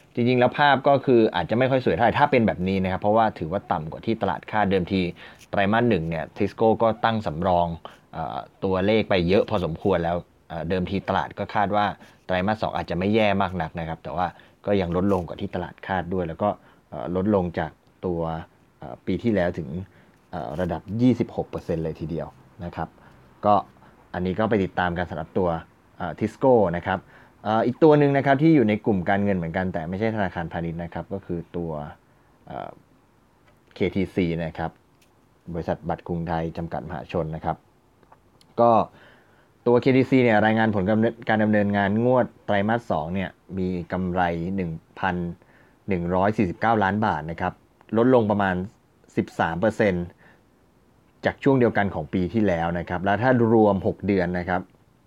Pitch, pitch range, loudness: 95 Hz, 90-110 Hz, -24 LUFS